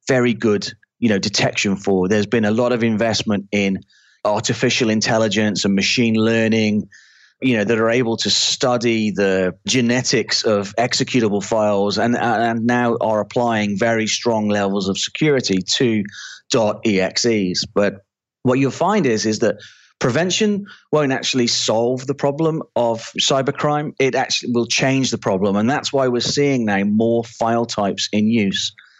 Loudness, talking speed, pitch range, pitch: -18 LUFS, 155 wpm, 105-125 Hz, 115 Hz